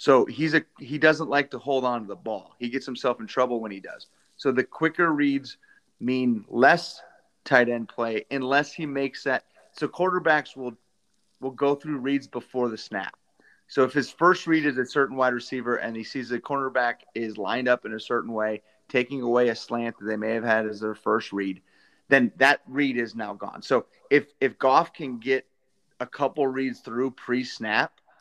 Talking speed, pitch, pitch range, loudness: 200 wpm, 130 Hz, 120-145 Hz, -25 LUFS